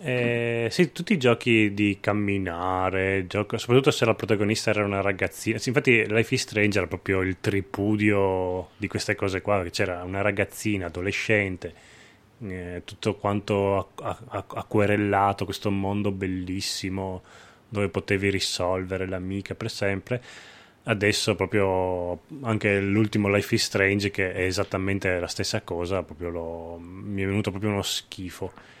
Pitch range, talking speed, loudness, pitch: 95-110 Hz, 140 wpm, -25 LUFS, 100 Hz